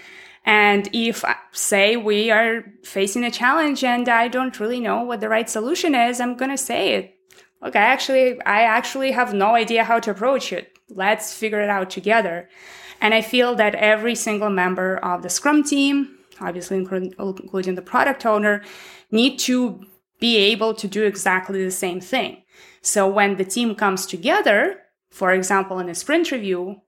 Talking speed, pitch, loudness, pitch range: 175 wpm, 215 Hz, -19 LUFS, 195-245 Hz